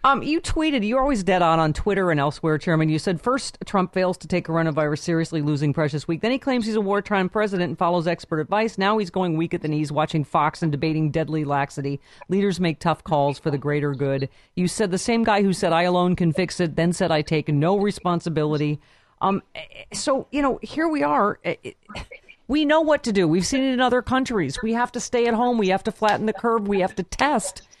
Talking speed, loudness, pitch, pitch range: 235 wpm, -22 LUFS, 185 Hz, 160-225 Hz